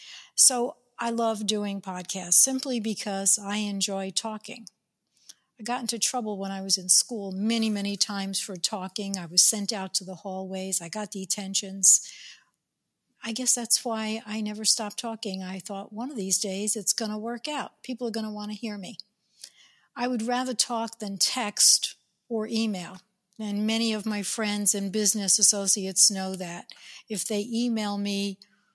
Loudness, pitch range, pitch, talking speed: -25 LUFS, 195-225 Hz, 210 Hz, 175 wpm